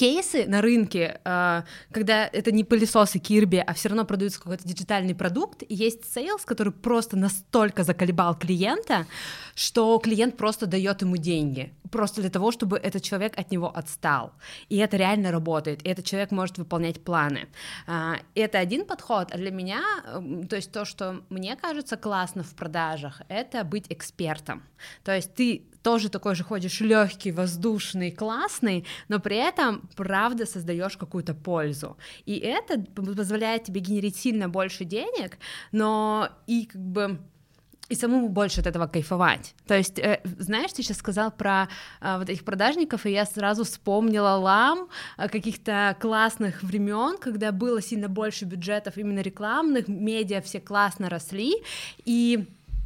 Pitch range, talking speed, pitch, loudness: 185-220 Hz, 150 wpm, 200 Hz, -26 LUFS